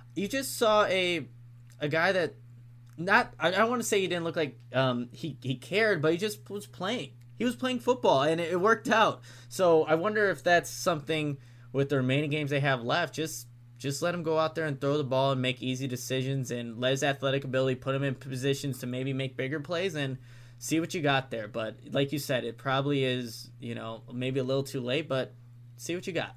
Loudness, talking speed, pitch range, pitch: -29 LUFS, 230 wpm, 125-165 Hz, 135 Hz